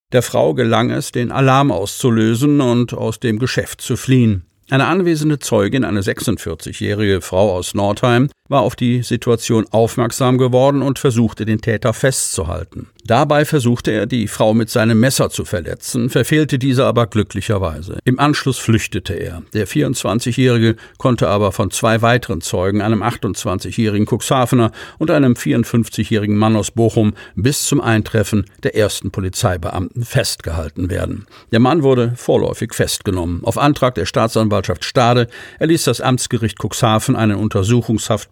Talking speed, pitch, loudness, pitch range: 140 wpm, 115 Hz, -16 LUFS, 105-125 Hz